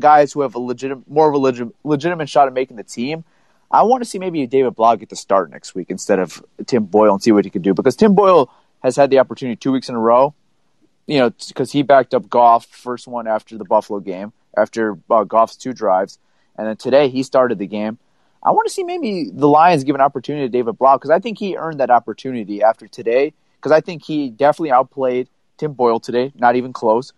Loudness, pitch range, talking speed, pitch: -16 LUFS, 115-150 Hz, 240 wpm, 130 Hz